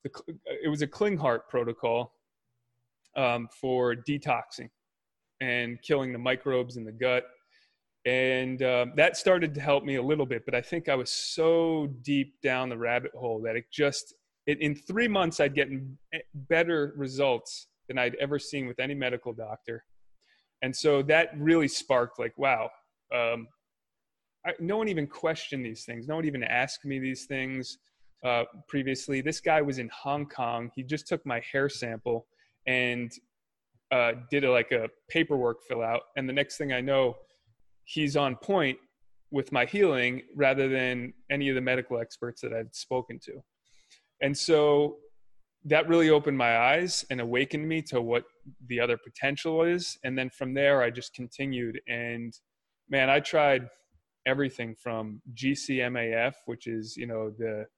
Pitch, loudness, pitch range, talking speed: 130 Hz, -28 LUFS, 120-145 Hz, 165 wpm